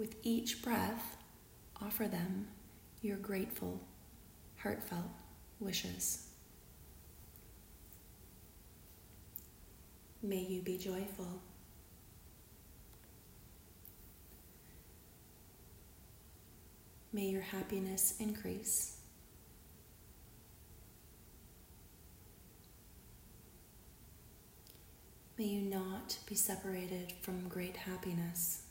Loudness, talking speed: -40 LUFS, 50 wpm